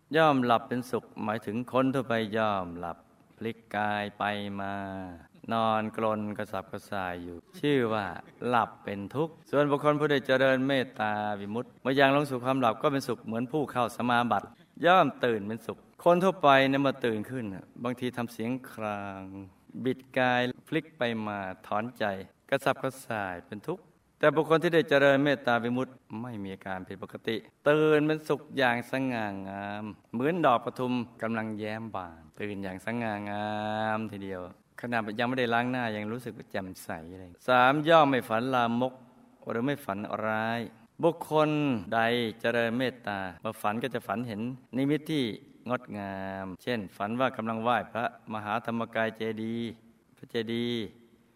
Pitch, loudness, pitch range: 115 Hz, -29 LUFS, 105-130 Hz